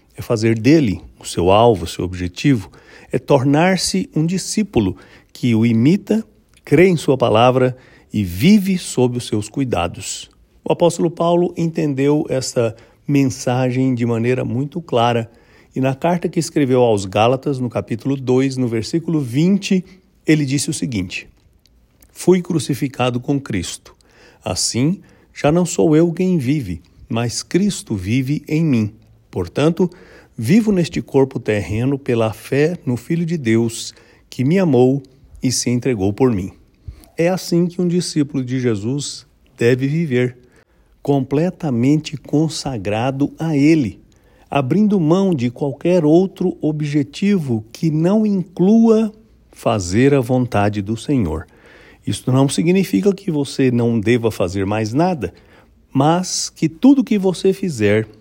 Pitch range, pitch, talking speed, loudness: 115-170 Hz, 135 Hz, 135 wpm, -17 LUFS